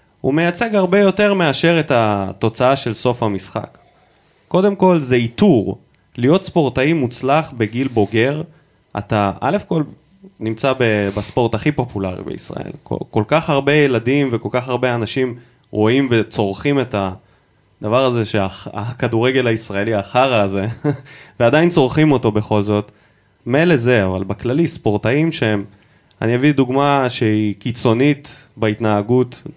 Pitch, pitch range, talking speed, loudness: 125 Hz, 105-145 Hz, 125 wpm, -17 LUFS